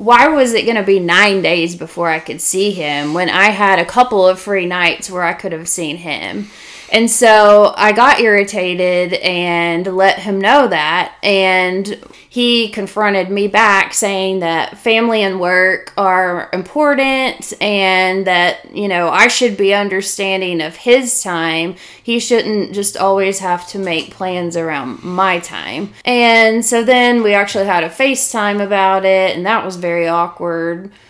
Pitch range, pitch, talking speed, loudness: 175-215 Hz, 195 Hz, 165 wpm, -13 LUFS